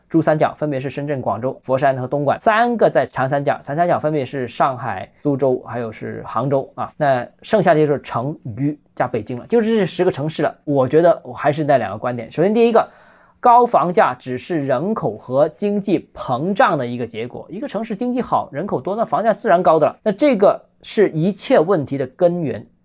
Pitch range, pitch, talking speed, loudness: 130-200 Hz, 145 Hz, 315 characters per minute, -18 LUFS